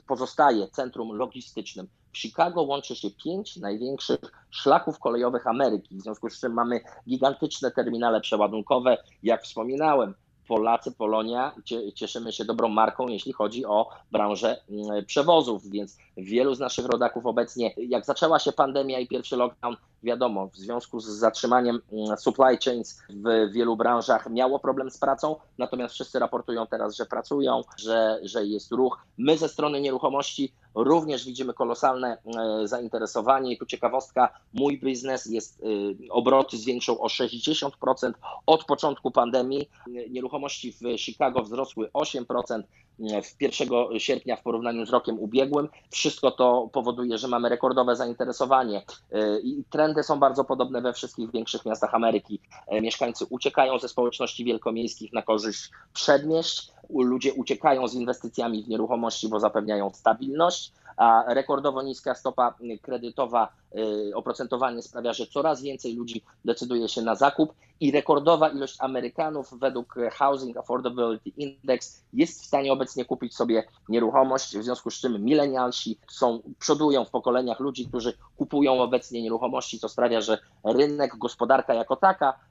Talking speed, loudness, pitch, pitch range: 135 wpm, -26 LUFS, 125 Hz, 115-135 Hz